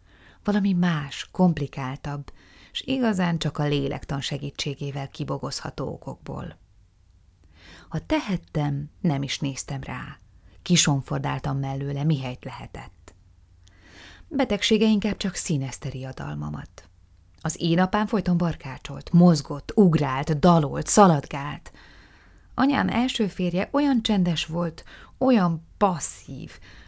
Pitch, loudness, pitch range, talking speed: 145 Hz, -24 LUFS, 125-180 Hz, 100 wpm